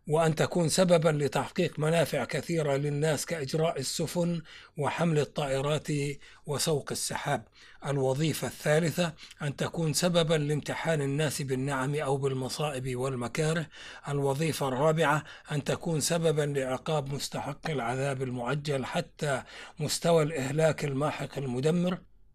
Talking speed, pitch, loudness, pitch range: 100 wpm, 150 Hz, -29 LUFS, 135-160 Hz